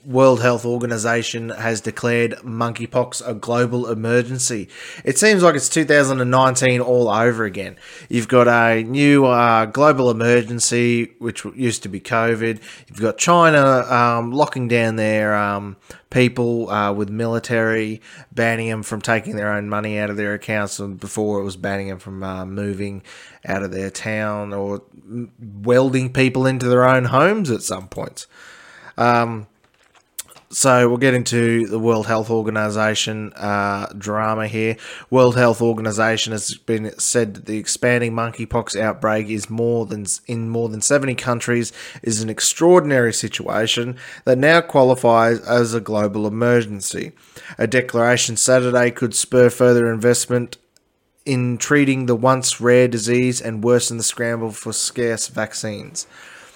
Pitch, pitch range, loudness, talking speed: 115 Hz, 110-125 Hz, -18 LUFS, 145 wpm